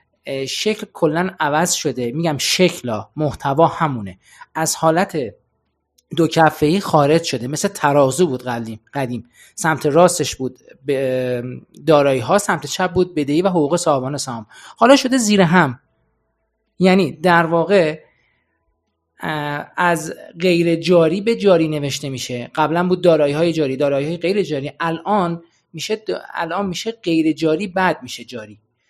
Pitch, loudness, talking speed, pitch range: 155 Hz, -18 LUFS, 135 wpm, 130-175 Hz